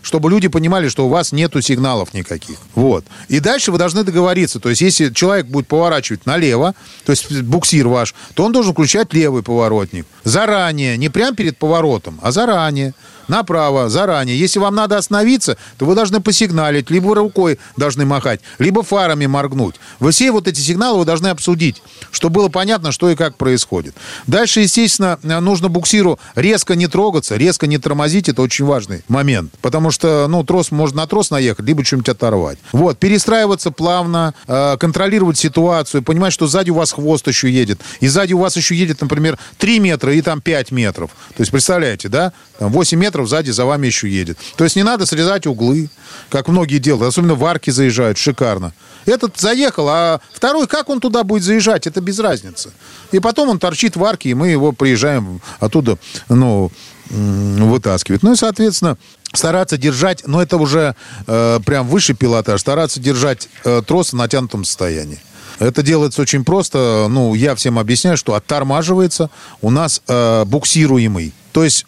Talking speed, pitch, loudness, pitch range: 175 wpm, 150 Hz, -14 LUFS, 125-180 Hz